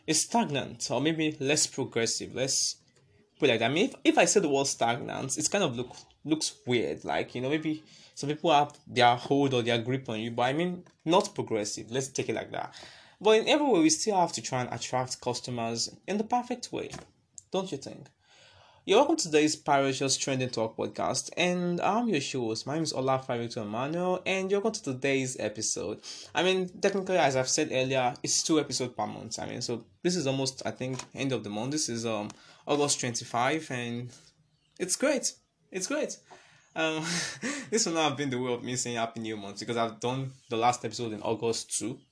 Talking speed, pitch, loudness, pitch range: 220 wpm, 135 Hz, -29 LUFS, 120-160 Hz